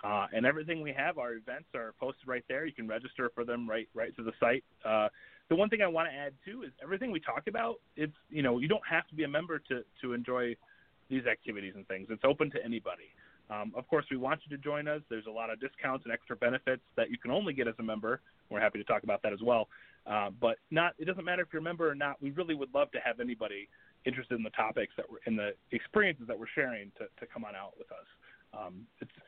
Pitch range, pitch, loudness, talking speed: 115-150 Hz, 130 Hz, -34 LUFS, 265 wpm